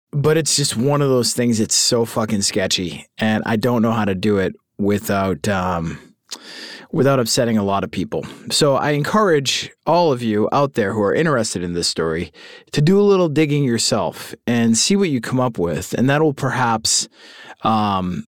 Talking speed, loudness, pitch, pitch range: 195 wpm, -18 LUFS, 115 Hz, 100-140 Hz